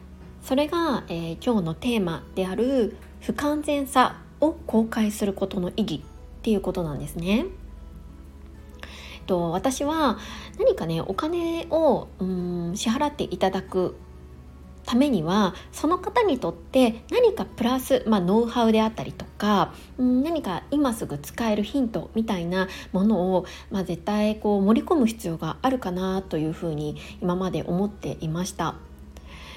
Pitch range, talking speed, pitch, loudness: 170-255 Hz, 290 characters per minute, 200 Hz, -25 LUFS